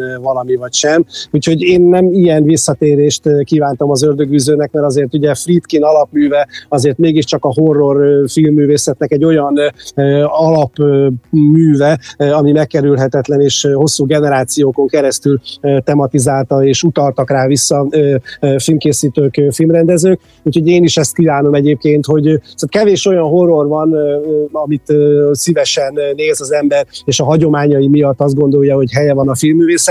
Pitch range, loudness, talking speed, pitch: 140-155 Hz, -11 LUFS, 130 wpm, 145 Hz